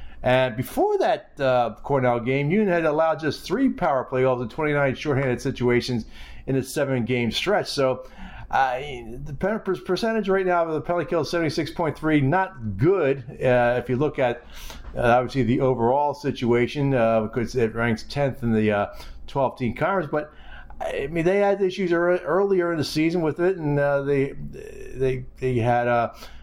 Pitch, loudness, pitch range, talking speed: 135 Hz, -23 LUFS, 120-170 Hz, 175 wpm